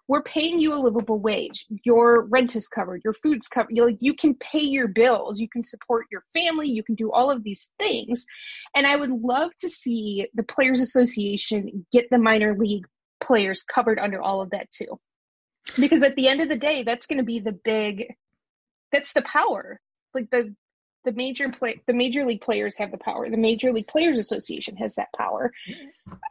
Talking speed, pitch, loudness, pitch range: 195 wpm, 245 Hz, -23 LUFS, 220-280 Hz